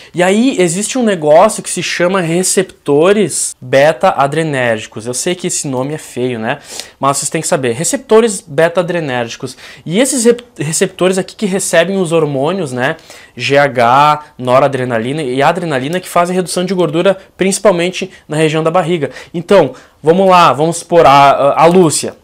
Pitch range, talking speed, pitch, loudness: 140-185 Hz, 155 wpm, 170 Hz, -12 LUFS